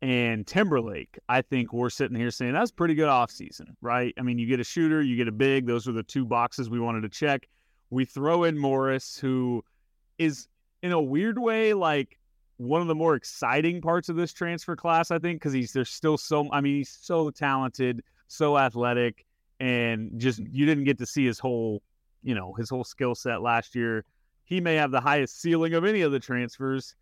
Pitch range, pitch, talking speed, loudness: 120-155 Hz, 130 Hz, 215 wpm, -27 LUFS